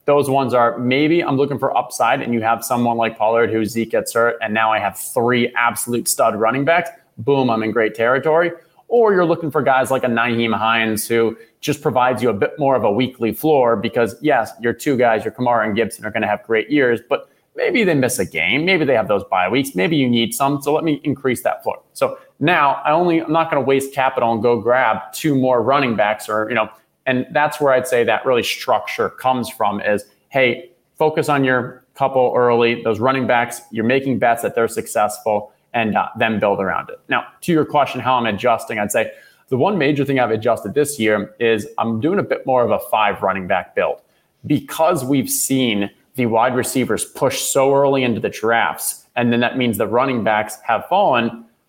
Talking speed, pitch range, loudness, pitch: 220 wpm, 115-140 Hz, -18 LUFS, 125 Hz